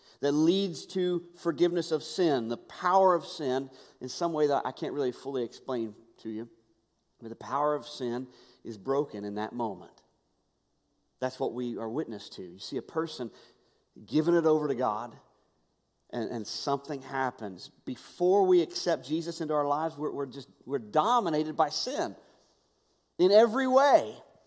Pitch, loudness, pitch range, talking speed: 140 Hz, -29 LUFS, 115-170 Hz, 170 wpm